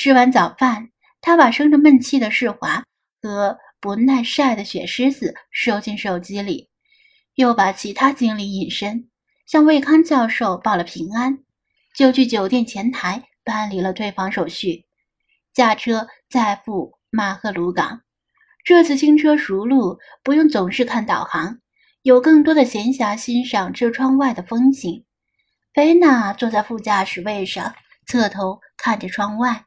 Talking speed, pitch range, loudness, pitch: 215 characters per minute, 200-270 Hz, -17 LUFS, 235 Hz